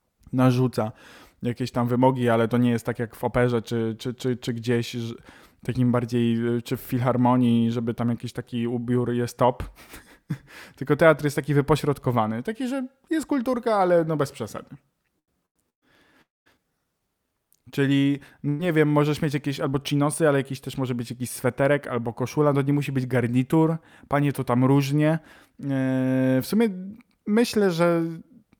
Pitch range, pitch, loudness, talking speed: 120-150 Hz, 130 Hz, -24 LUFS, 155 wpm